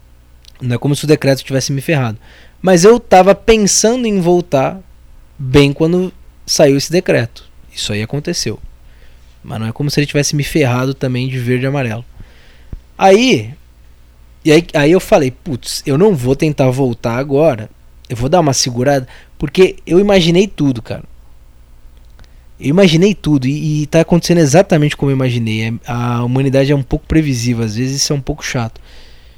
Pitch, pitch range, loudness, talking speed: 135 Hz, 110-160 Hz, -13 LUFS, 170 wpm